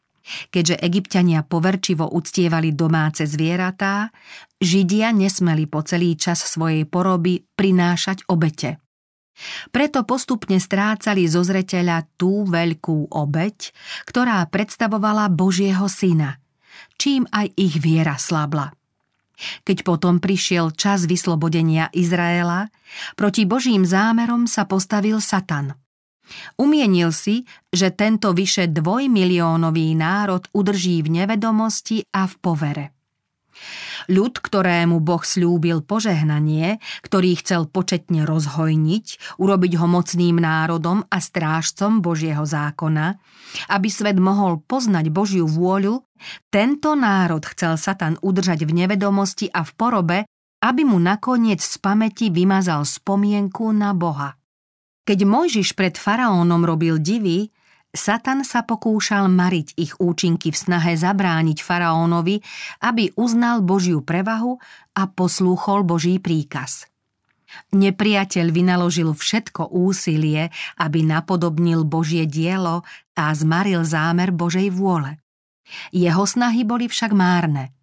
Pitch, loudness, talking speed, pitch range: 180 Hz, -19 LUFS, 110 wpm, 165-205 Hz